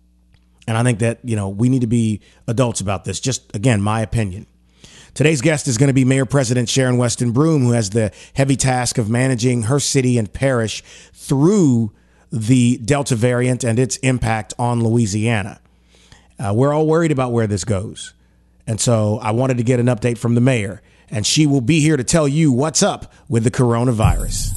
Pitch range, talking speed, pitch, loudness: 110-130 Hz, 195 wpm, 120 Hz, -17 LUFS